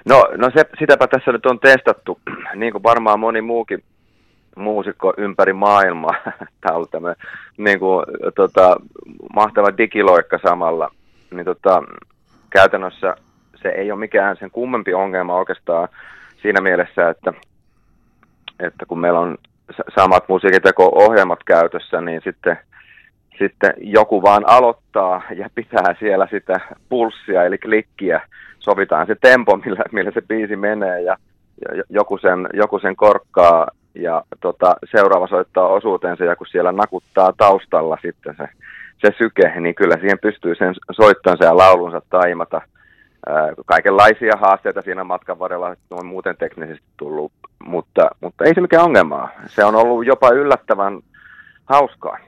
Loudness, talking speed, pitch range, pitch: -15 LUFS, 140 wpm, 90-110 Hz, 100 Hz